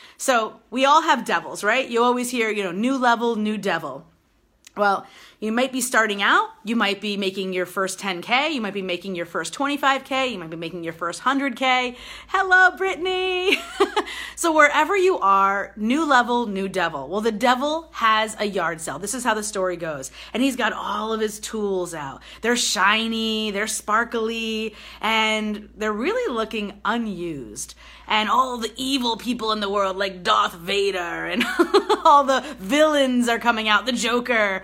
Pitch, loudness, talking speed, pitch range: 225 Hz, -21 LUFS, 175 wpm, 200-265 Hz